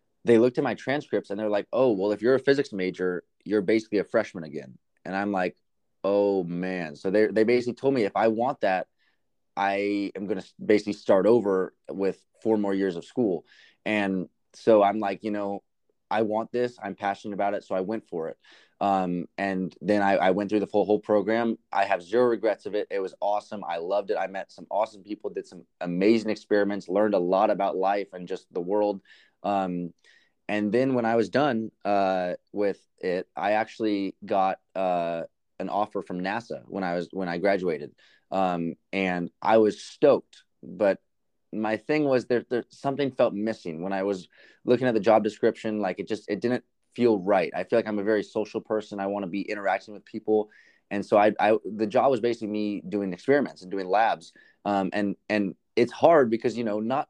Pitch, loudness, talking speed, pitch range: 105 Hz, -26 LUFS, 205 wpm, 95-110 Hz